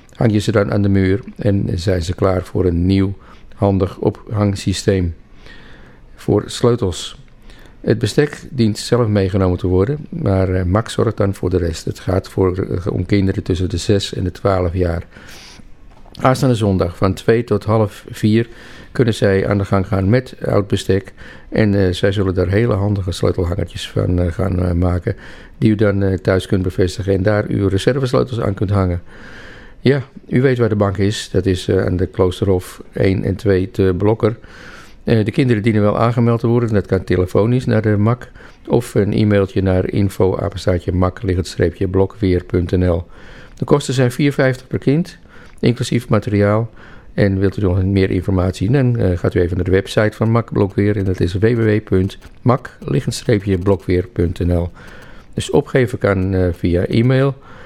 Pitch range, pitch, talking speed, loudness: 95-110 Hz, 100 Hz, 155 wpm, -17 LUFS